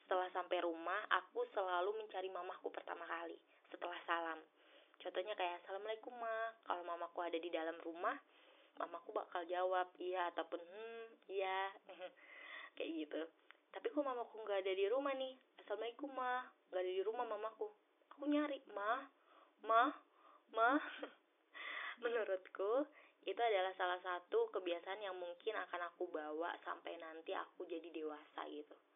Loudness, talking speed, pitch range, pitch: -43 LUFS, 140 wpm, 175-235 Hz, 190 Hz